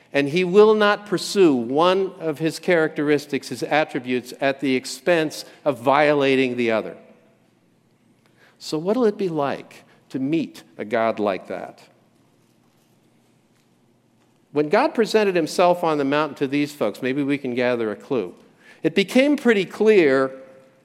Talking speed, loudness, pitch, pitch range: 140 wpm, -20 LUFS, 150 Hz, 135-190 Hz